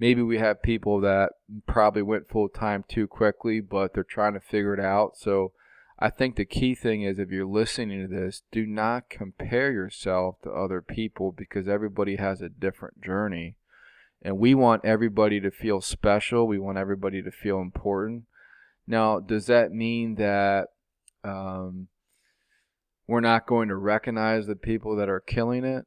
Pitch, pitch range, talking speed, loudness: 105 Hz, 95-115 Hz, 170 wpm, -26 LUFS